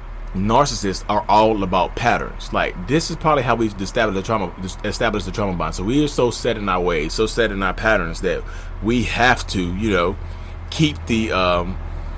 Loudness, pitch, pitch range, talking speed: -20 LUFS, 100 Hz, 90-115 Hz, 195 wpm